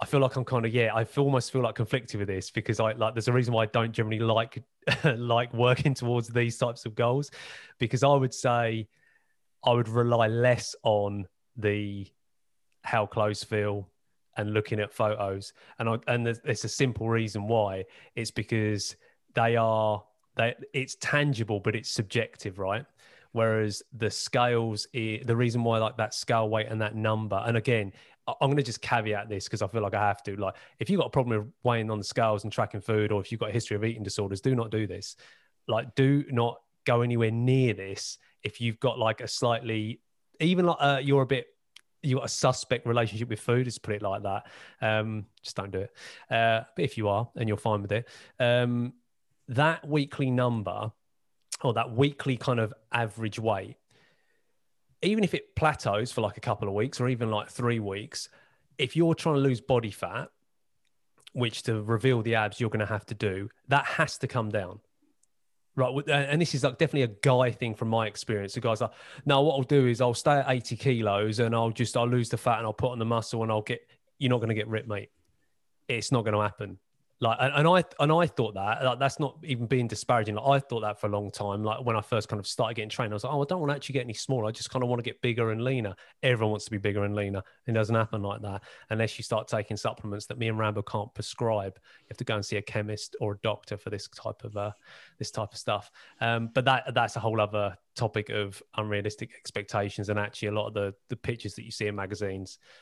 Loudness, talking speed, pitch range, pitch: -29 LUFS, 230 wpm, 105-125 Hz, 115 Hz